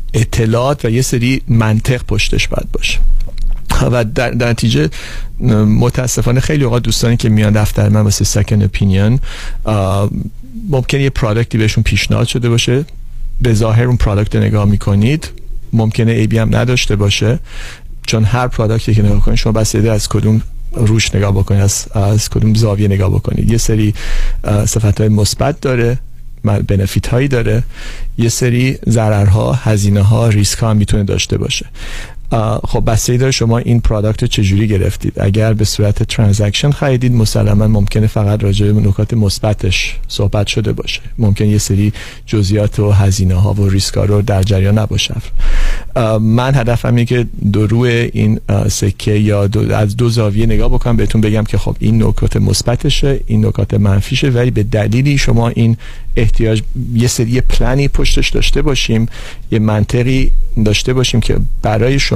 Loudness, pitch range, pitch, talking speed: -13 LUFS, 105-120 Hz, 110 Hz, 150 wpm